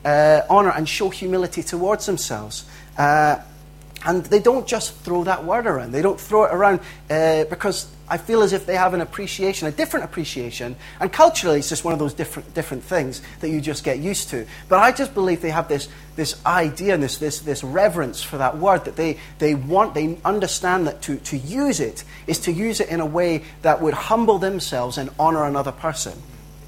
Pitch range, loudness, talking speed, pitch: 150-190 Hz, -20 LUFS, 210 wpm, 165 Hz